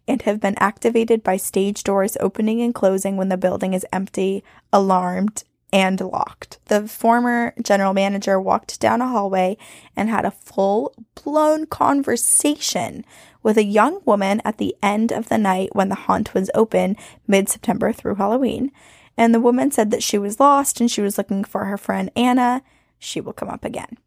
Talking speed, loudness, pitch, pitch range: 180 wpm, -19 LUFS, 210 Hz, 195-240 Hz